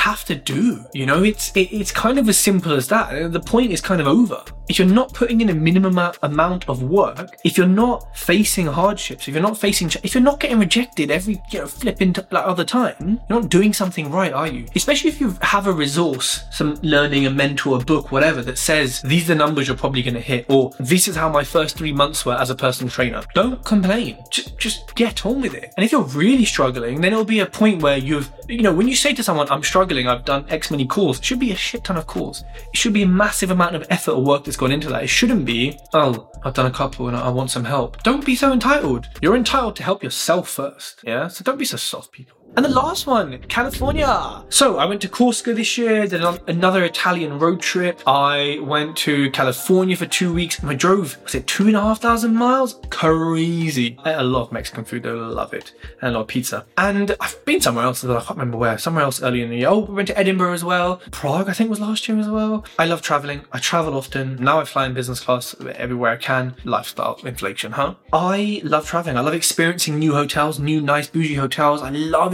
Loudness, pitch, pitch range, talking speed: -19 LUFS, 165 Hz, 140-205 Hz, 245 wpm